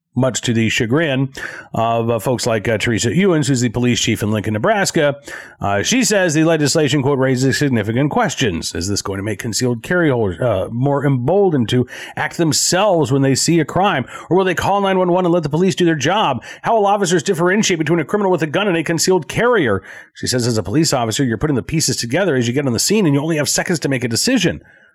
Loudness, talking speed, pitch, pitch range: -16 LUFS, 235 wpm, 145 Hz, 120-175 Hz